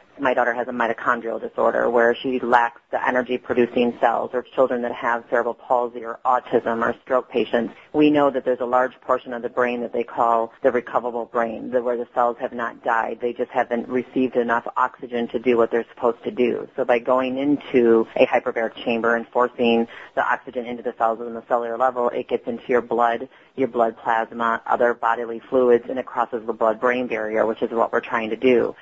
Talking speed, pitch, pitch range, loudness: 210 wpm, 120 Hz, 115-125 Hz, -22 LUFS